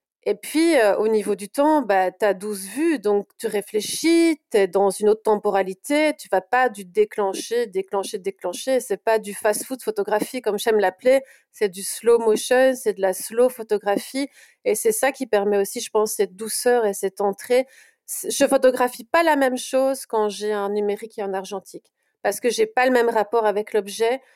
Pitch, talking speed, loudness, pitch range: 220 Hz, 195 wpm, -21 LUFS, 205-265 Hz